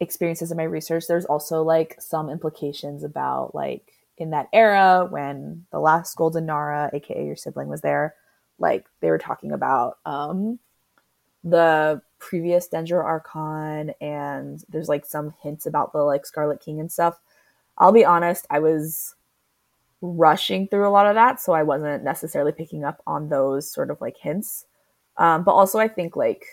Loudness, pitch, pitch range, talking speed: -22 LUFS, 160 Hz, 145-175 Hz, 170 wpm